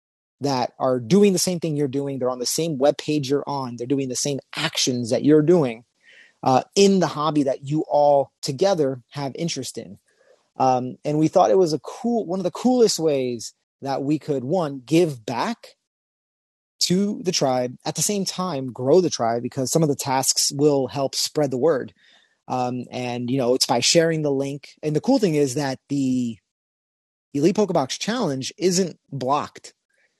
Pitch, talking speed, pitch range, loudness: 145 Hz, 190 wpm, 130-165 Hz, -22 LUFS